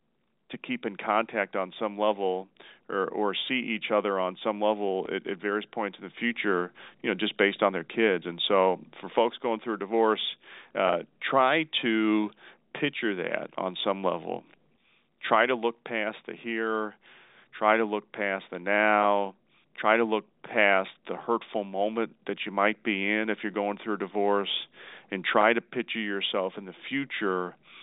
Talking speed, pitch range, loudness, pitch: 180 wpm, 100-110 Hz, -28 LUFS, 105 Hz